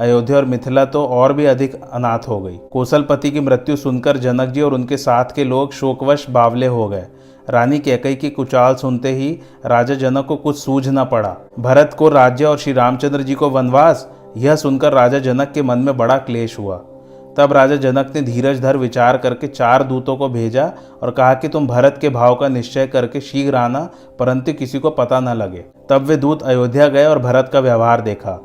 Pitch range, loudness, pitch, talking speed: 125-140 Hz, -15 LUFS, 130 Hz, 205 wpm